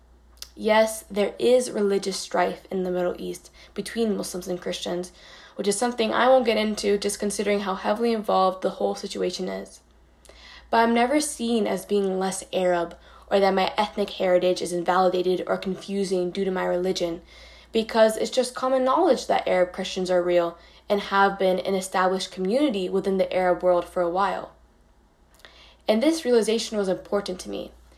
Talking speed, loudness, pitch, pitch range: 170 wpm, -24 LUFS, 190 Hz, 180-215 Hz